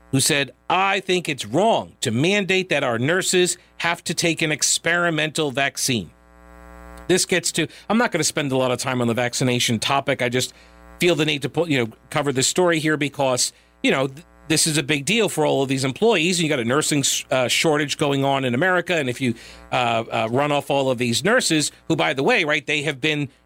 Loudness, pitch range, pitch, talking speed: -20 LUFS, 125-165 Hz, 145 Hz, 235 wpm